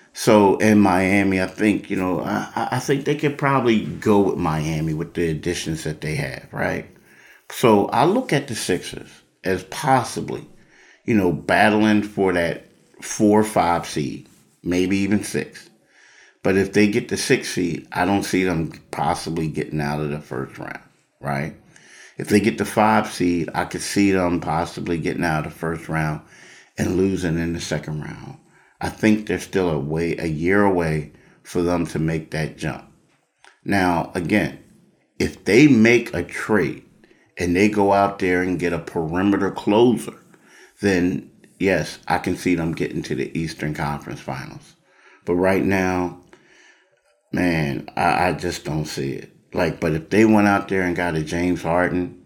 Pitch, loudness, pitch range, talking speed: 90 Hz, -21 LUFS, 80-100 Hz, 175 wpm